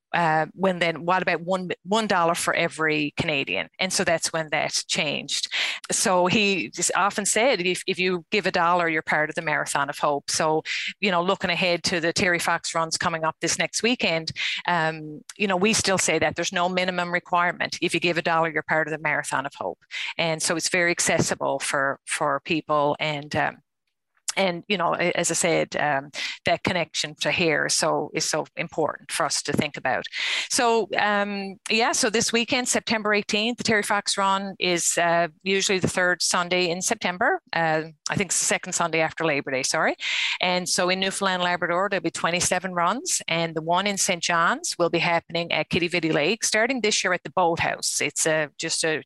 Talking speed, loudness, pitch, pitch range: 205 wpm, -23 LUFS, 175 Hz, 160-195 Hz